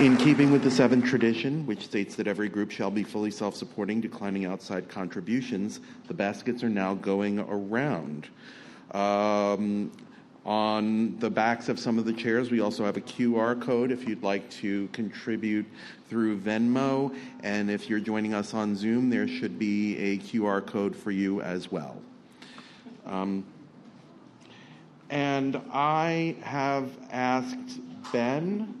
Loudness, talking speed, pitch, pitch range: -28 LUFS, 145 wpm, 110 Hz, 100-125 Hz